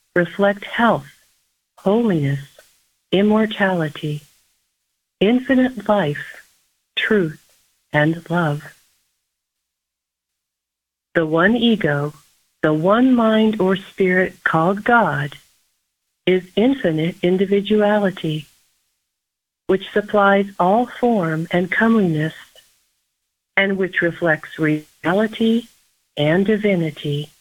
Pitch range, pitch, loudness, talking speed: 150-205 Hz, 180 Hz, -18 LUFS, 75 wpm